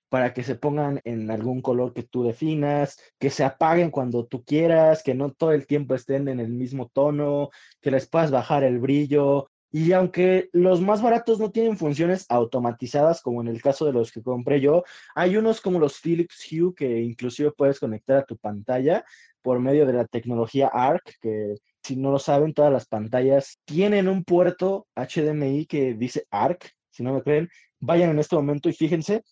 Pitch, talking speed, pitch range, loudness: 140 Hz, 190 wpm, 125-160 Hz, -23 LUFS